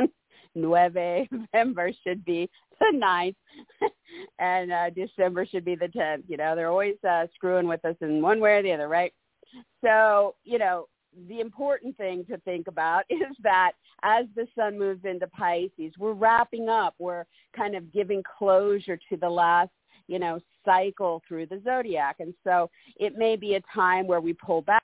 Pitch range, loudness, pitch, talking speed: 175-215 Hz, -26 LUFS, 185 Hz, 175 wpm